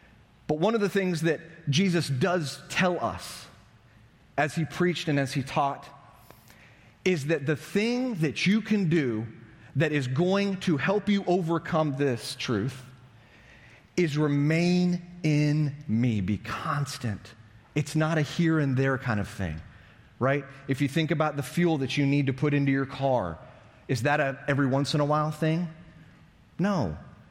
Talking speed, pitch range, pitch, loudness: 165 wpm, 130-165 Hz, 145 Hz, -27 LUFS